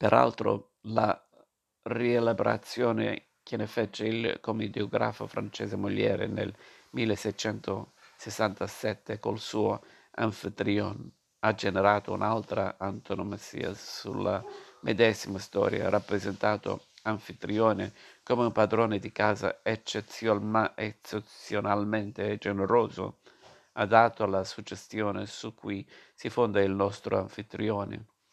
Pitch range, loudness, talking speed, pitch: 100-110 Hz, -30 LUFS, 85 wpm, 105 Hz